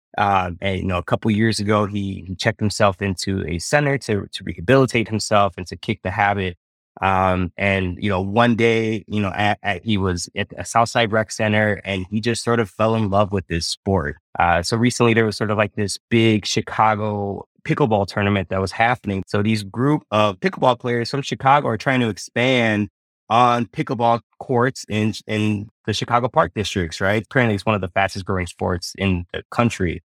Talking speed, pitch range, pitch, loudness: 200 wpm, 95-115 Hz, 105 Hz, -20 LUFS